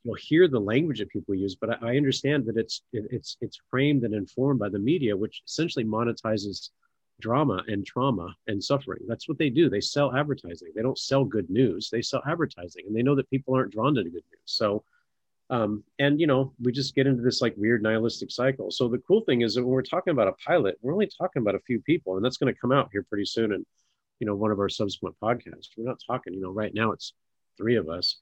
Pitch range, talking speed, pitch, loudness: 105-135 Hz, 250 wpm, 120 Hz, -27 LUFS